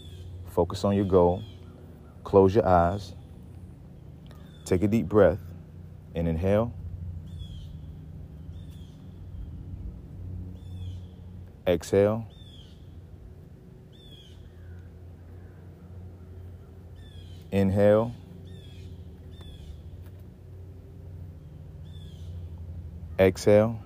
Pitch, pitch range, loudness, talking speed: 90 Hz, 85-90 Hz, -25 LUFS, 40 wpm